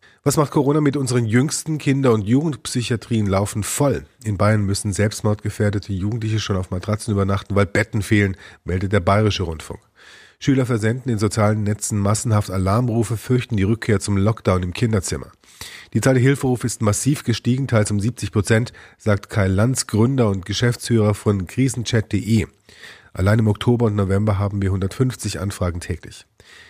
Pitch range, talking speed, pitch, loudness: 100-120 Hz, 155 wpm, 105 Hz, -20 LUFS